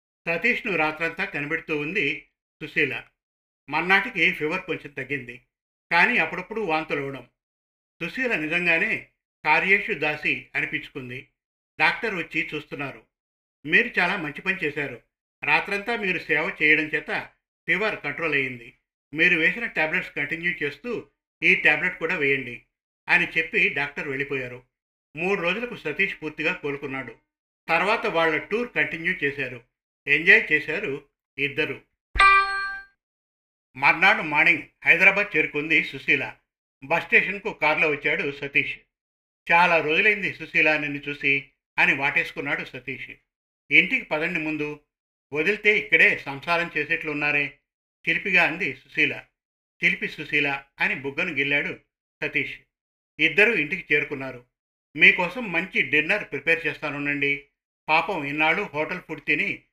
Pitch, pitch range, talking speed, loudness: 155 Hz, 140-175 Hz, 105 wpm, -22 LUFS